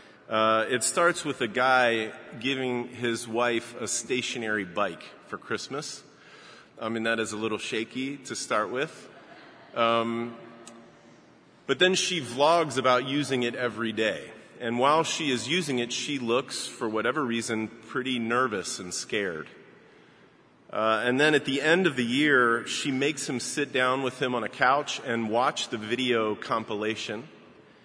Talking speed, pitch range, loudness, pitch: 155 wpm, 115-135 Hz, -27 LUFS, 120 Hz